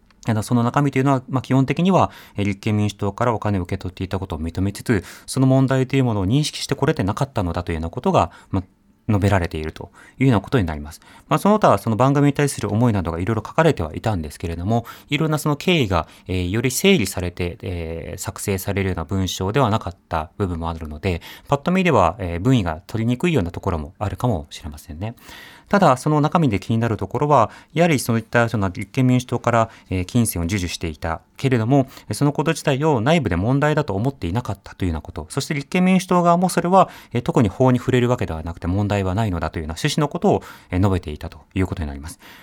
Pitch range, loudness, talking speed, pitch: 90-135 Hz, -20 LUFS, 470 characters per minute, 110 Hz